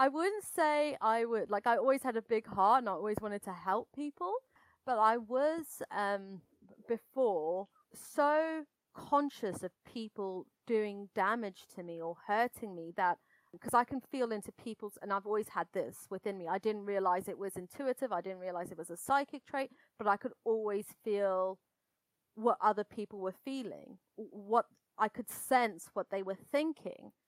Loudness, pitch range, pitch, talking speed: -35 LUFS, 195-260 Hz, 215 Hz, 180 wpm